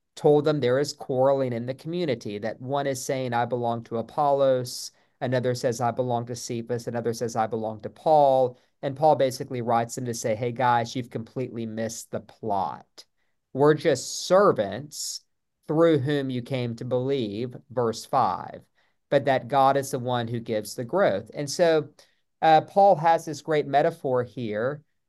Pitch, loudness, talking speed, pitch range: 130 Hz, -25 LUFS, 170 wpm, 120-145 Hz